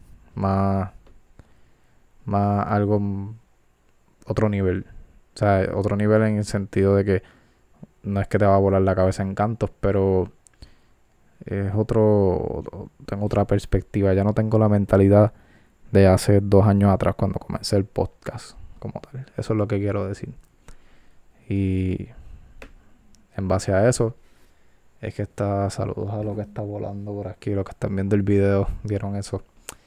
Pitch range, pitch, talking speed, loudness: 95-105 Hz, 100 Hz, 155 wpm, -22 LUFS